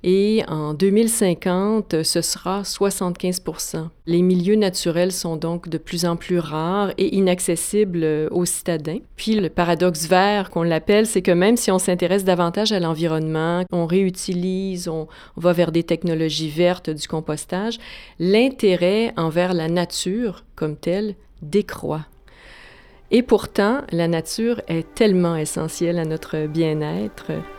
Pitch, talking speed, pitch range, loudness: 180 Hz, 135 wpm, 165-195 Hz, -20 LUFS